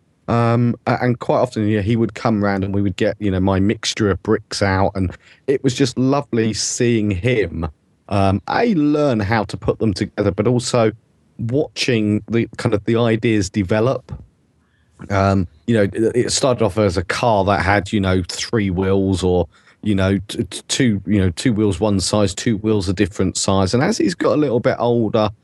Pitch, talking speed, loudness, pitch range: 105 Hz, 200 wpm, -18 LUFS, 95-115 Hz